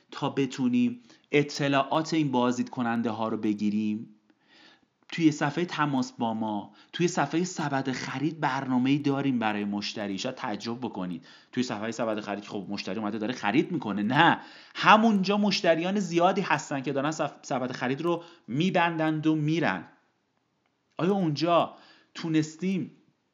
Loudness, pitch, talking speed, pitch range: -27 LUFS, 140 Hz, 130 wpm, 115-165 Hz